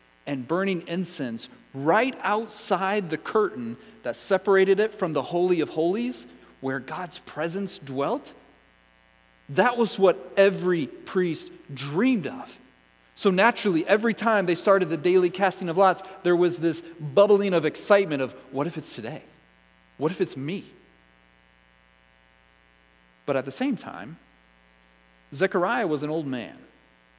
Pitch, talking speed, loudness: 165 Hz, 135 wpm, -25 LUFS